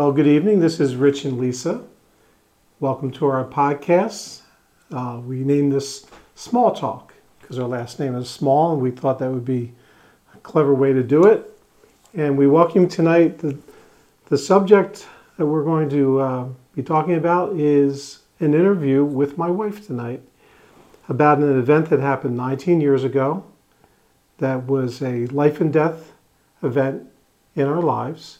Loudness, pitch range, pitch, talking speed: -19 LUFS, 135-165 Hz, 145 Hz, 160 wpm